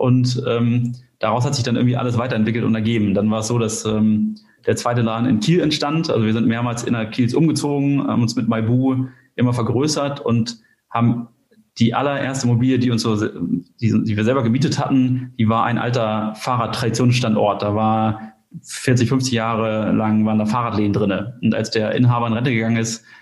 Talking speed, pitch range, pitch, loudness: 185 wpm, 110-125 Hz, 120 Hz, -19 LUFS